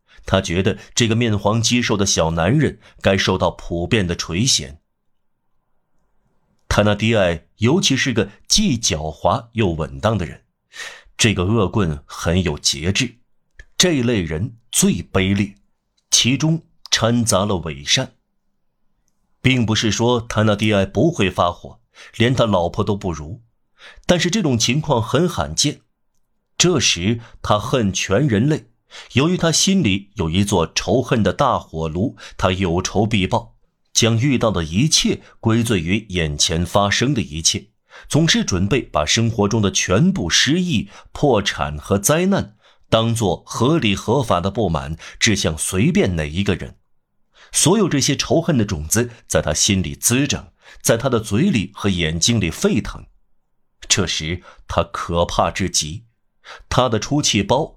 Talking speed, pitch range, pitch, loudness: 210 characters per minute, 90-125 Hz, 105 Hz, -18 LUFS